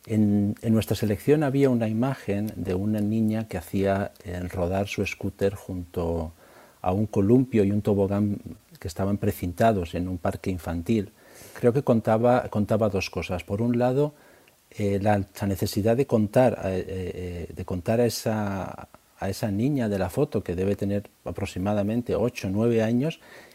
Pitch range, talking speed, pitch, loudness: 95-115 Hz, 165 wpm, 105 Hz, -26 LUFS